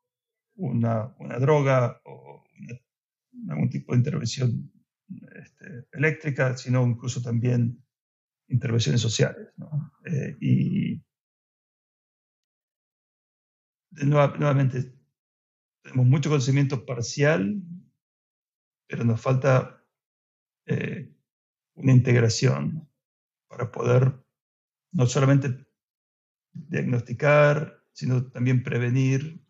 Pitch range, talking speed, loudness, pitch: 125-150 Hz, 75 wpm, -24 LUFS, 130 Hz